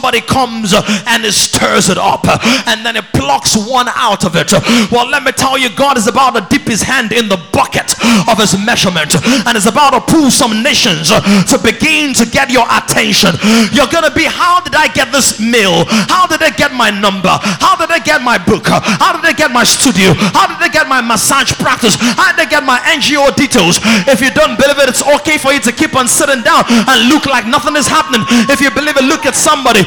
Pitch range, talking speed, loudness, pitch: 225-290 Hz, 230 wpm, -9 LUFS, 255 Hz